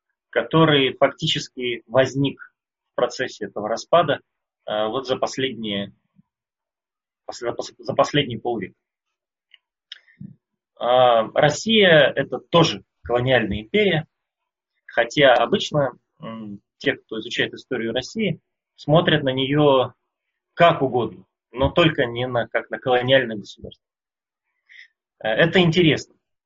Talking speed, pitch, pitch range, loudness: 90 wpm, 135 Hz, 120-155 Hz, -20 LUFS